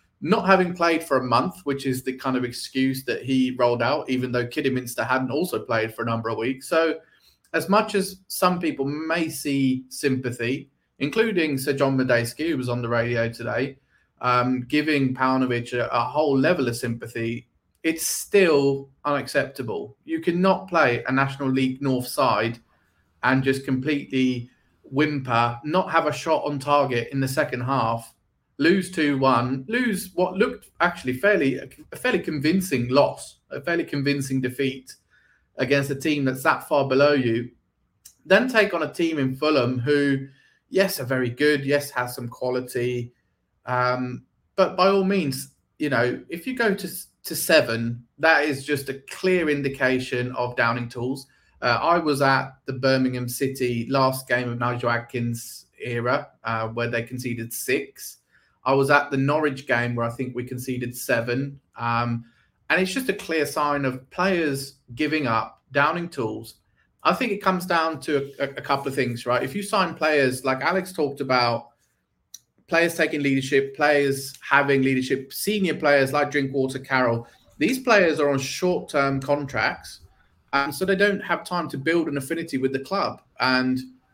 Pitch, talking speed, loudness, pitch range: 135 Hz, 170 wpm, -23 LUFS, 125-155 Hz